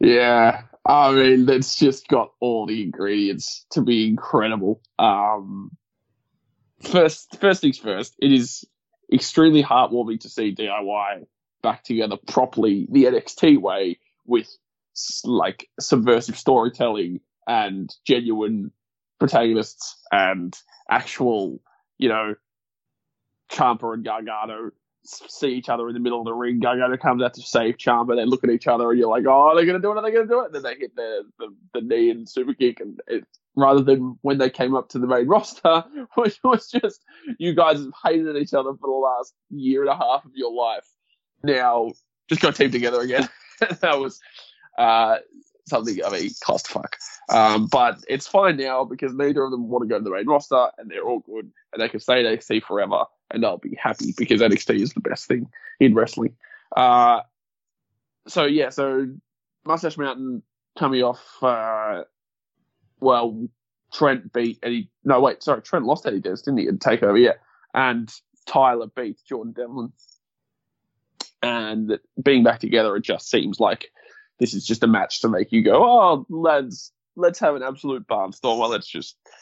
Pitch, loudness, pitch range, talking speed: 130 Hz, -21 LUFS, 120-165 Hz, 175 wpm